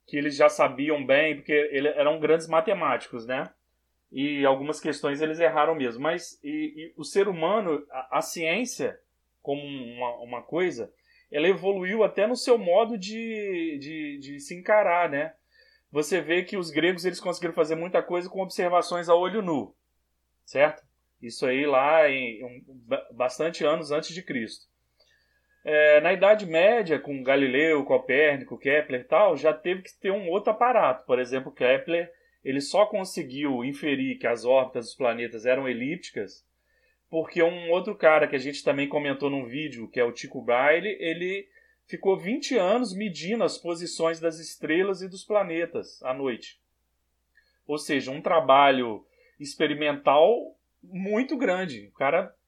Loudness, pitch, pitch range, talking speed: -25 LUFS, 155 Hz, 135-185 Hz, 155 wpm